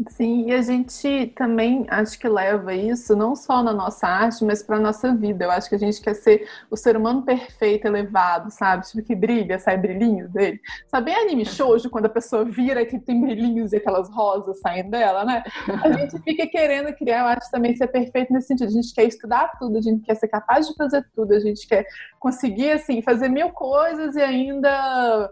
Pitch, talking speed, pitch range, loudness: 235 Hz, 210 wpm, 215-255 Hz, -21 LUFS